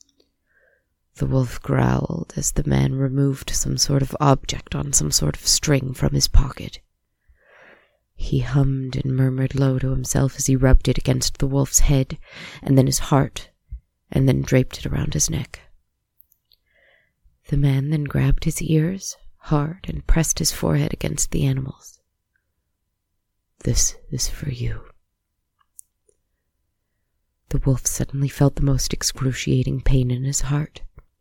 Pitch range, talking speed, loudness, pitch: 100-140 Hz, 140 wpm, -21 LUFS, 130 Hz